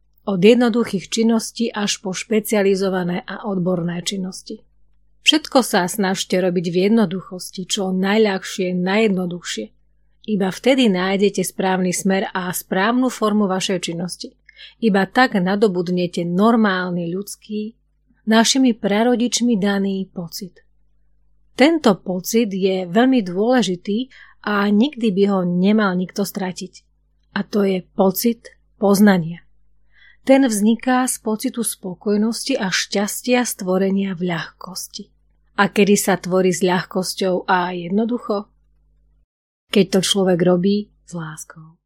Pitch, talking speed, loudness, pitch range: 195 Hz, 110 wpm, -18 LUFS, 185-220 Hz